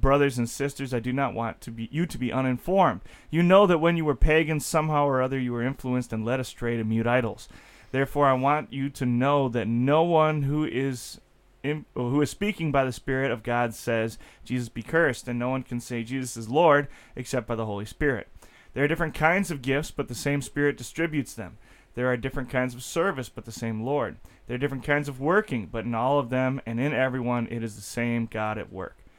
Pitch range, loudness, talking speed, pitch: 120-145 Hz, -26 LUFS, 230 wpm, 130 Hz